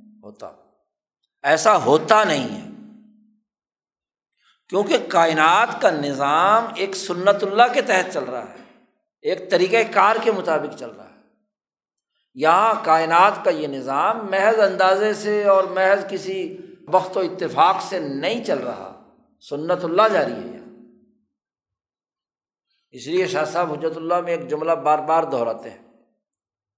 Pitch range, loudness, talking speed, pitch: 160-220 Hz, -19 LUFS, 135 wpm, 195 Hz